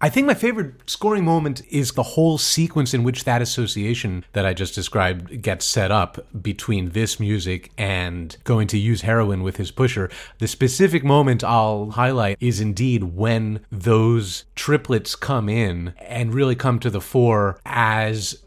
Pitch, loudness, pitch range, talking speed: 115 Hz, -21 LUFS, 105-130 Hz, 165 wpm